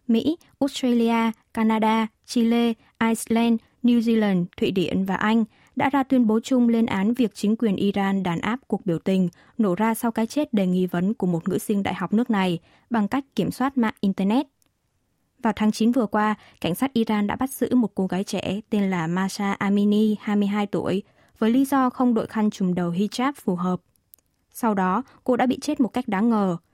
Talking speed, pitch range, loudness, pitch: 205 wpm, 195-235 Hz, -23 LUFS, 220 Hz